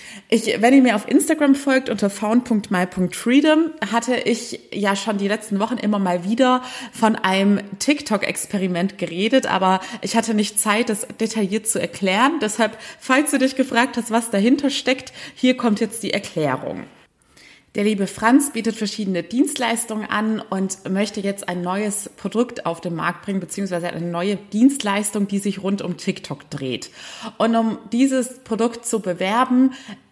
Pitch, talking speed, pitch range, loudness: 220 Hz, 155 wpm, 195-240 Hz, -20 LUFS